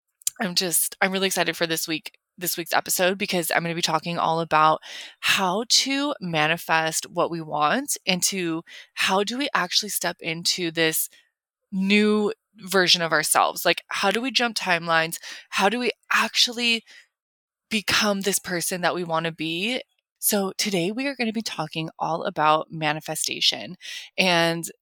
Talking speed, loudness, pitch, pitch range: 165 wpm, -23 LUFS, 180 Hz, 165-210 Hz